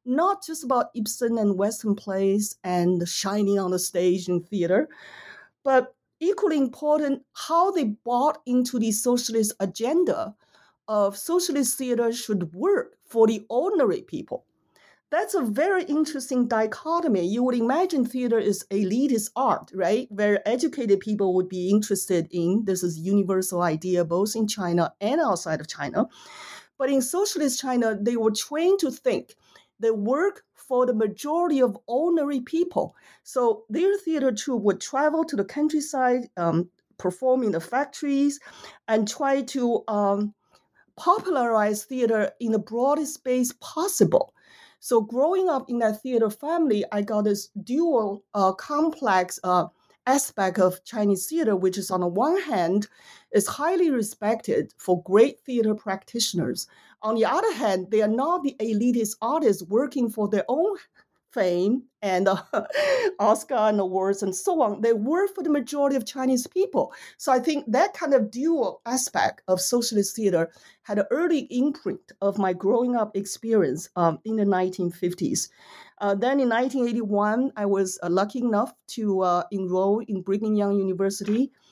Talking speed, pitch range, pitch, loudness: 155 wpm, 200-275 Hz, 225 Hz, -24 LUFS